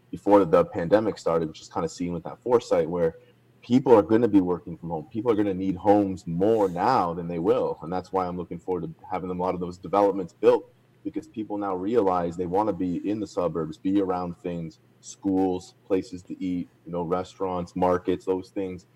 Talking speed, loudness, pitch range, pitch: 210 wpm, -25 LUFS, 90-100 Hz, 95 Hz